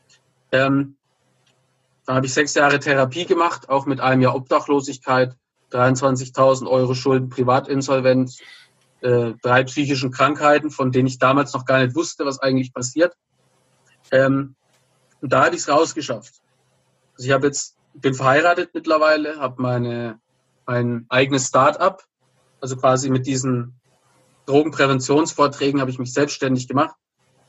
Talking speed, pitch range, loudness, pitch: 135 wpm, 130-140 Hz, -19 LUFS, 135 Hz